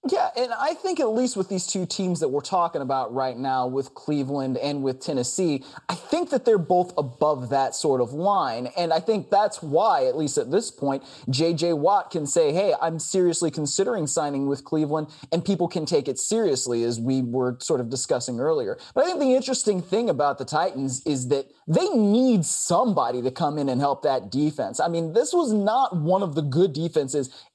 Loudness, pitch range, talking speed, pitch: -24 LUFS, 140-205 Hz, 210 wpm, 165 Hz